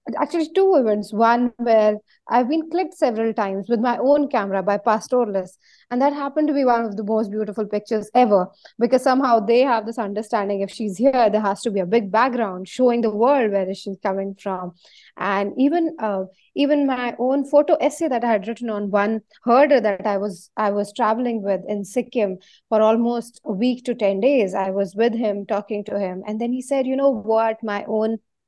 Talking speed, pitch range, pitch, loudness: 205 wpm, 205-250 Hz, 225 Hz, -20 LUFS